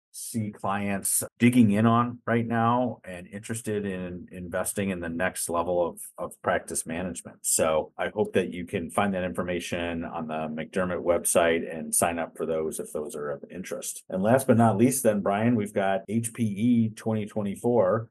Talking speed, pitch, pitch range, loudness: 175 wpm, 100 Hz, 90-115 Hz, -26 LUFS